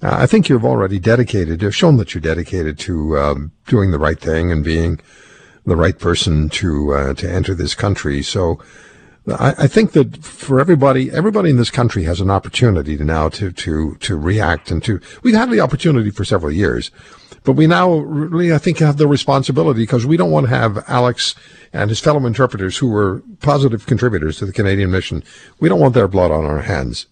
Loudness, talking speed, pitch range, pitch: -15 LUFS, 205 wpm, 85-140 Hz, 105 Hz